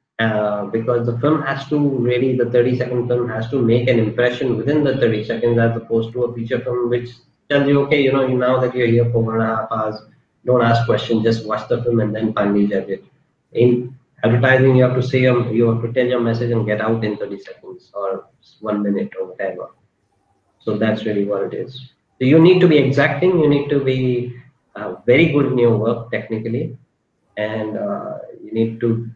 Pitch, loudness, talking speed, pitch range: 120 Hz, -18 LUFS, 220 wpm, 115-130 Hz